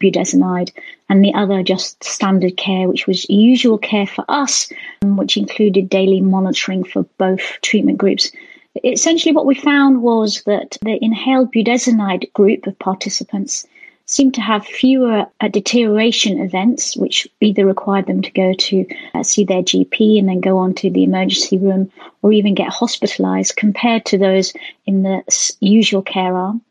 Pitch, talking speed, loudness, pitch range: 200 Hz, 155 wpm, -15 LUFS, 190-235 Hz